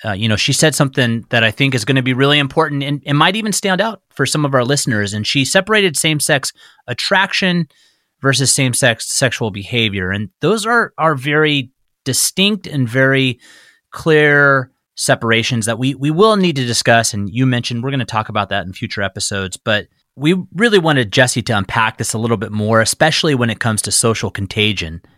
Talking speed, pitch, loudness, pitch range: 205 wpm, 130 Hz, -15 LUFS, 110-150 Hz